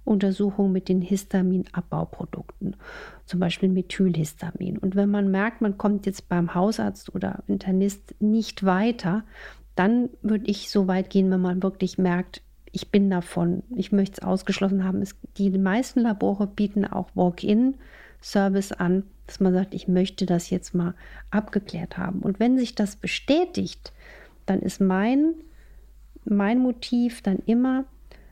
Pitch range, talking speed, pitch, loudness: 185-210 Hz, 145 wpm, 195 Hz, -24 LUFS